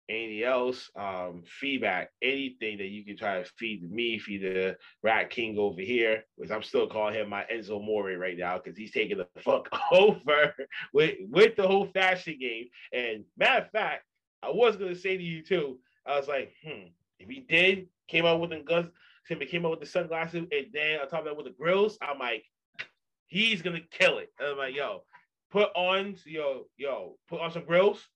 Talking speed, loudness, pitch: 205 wpm, -29 LUFS, 160 Hz